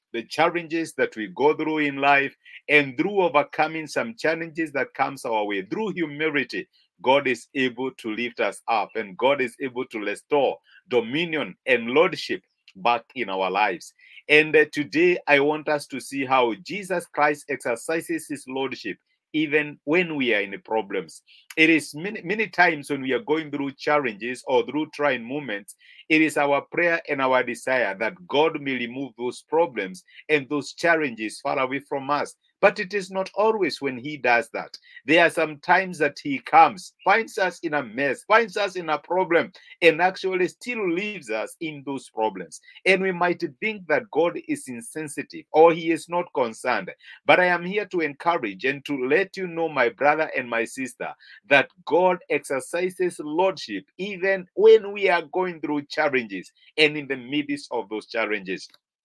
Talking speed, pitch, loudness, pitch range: 180 wpm, 155 Hz, -23 LUFS, 135-180 Hz